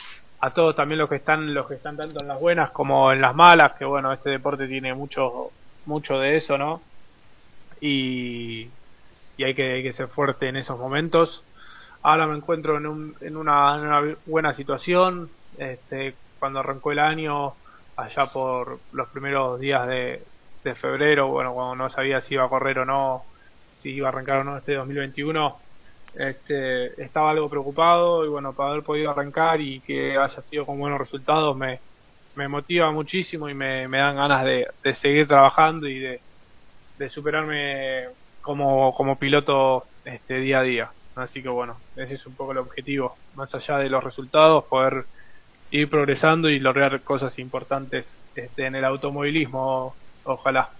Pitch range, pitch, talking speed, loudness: 130-150 Hz, 140 Hz, 175 wpm, -22 LUFS